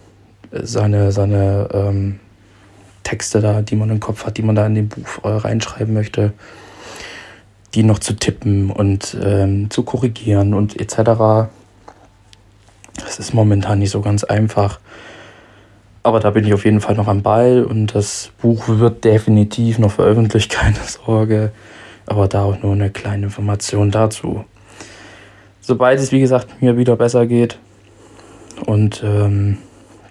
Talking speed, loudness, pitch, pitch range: 145 wpm, -16 LUFS, 105 Hz, 100-110 Hz